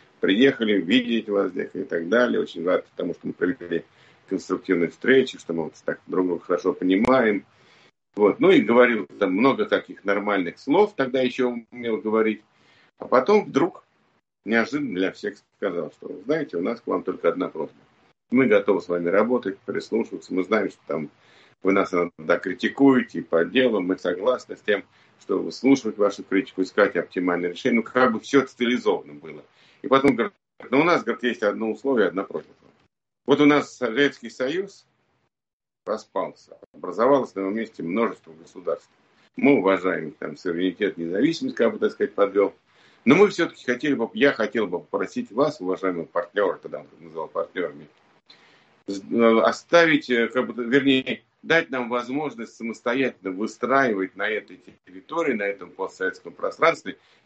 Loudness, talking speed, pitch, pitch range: -23 LUFS, 160 wpm, 120 Hz, 95-140 Hz